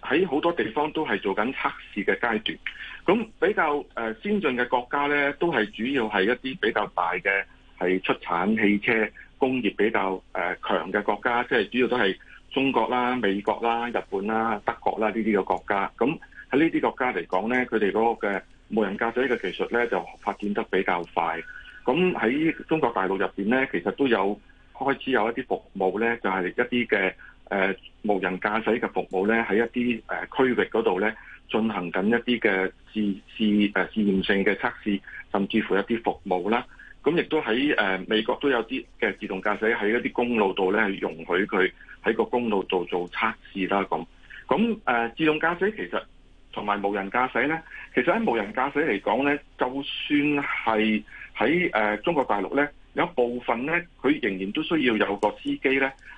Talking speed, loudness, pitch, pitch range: 280 characters per minute, -25 LUFS, 115 Hz, 100-135 Hz